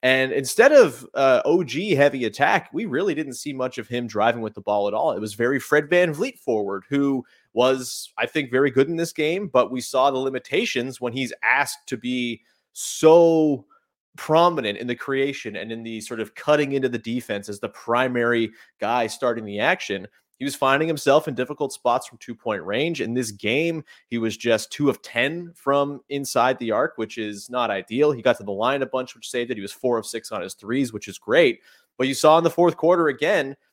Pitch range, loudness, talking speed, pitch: 115-145 Hz, -22 LUFS, 220 wpm, 130 Hz